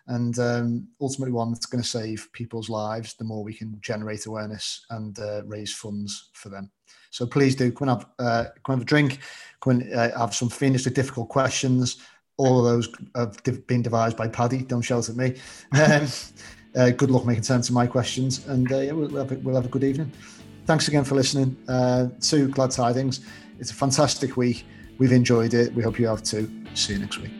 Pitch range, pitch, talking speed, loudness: 115-130 Hz, 120 Hz, 205 wpm, -24 LUFS